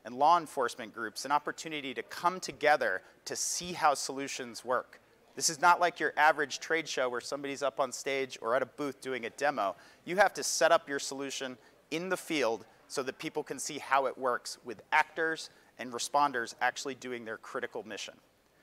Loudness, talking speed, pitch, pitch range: -32 LUFS, 195 wpm, 140 Hz, 130-160 Hz